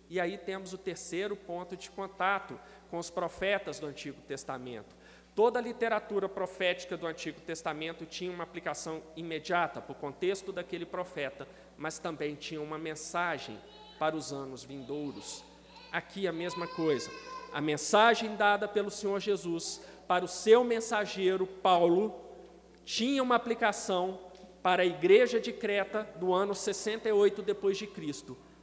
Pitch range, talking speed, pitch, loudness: 165-205 Hz, 140 wpm, 180 Hz, -32 LUFS